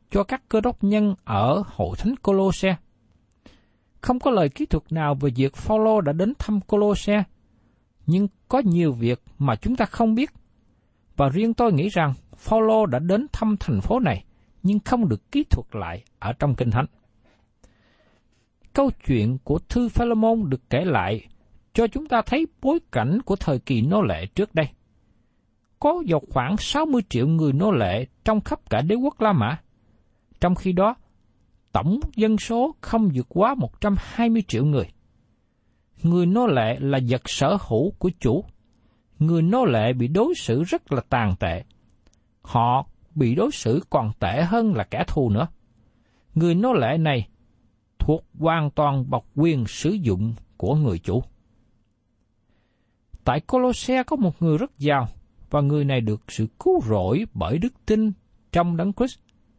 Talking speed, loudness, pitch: 165 wpm, -23 LUFS, 150 Hz